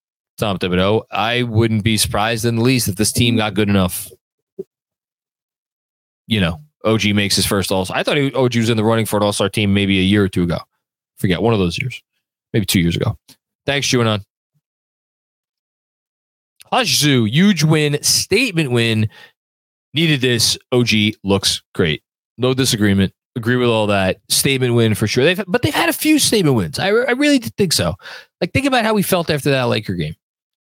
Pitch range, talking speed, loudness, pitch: 100-135 Hz, 190 wpm, -16 LUFS, 115 Hz